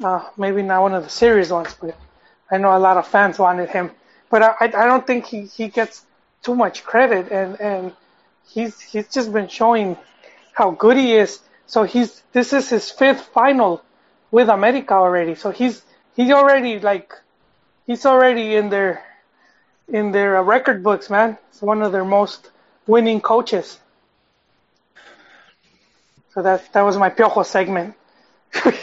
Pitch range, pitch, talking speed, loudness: 195-235 Hz, 215 Hz, 160 wpm, -17 LUFS